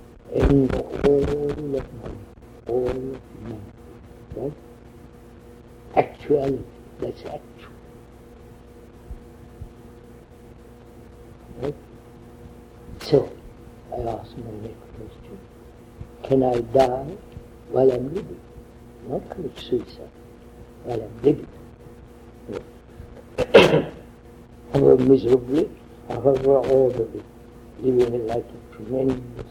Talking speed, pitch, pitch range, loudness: 85 wpm, 120 Hz, 120-130 Hz, -22 LUFS